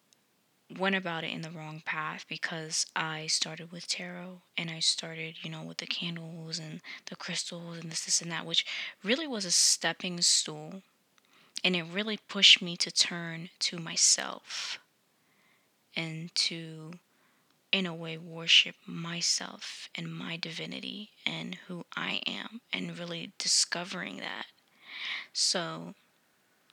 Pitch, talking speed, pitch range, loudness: 170 Hz, 140 wpm, 165-185 Hz, -29 LUFS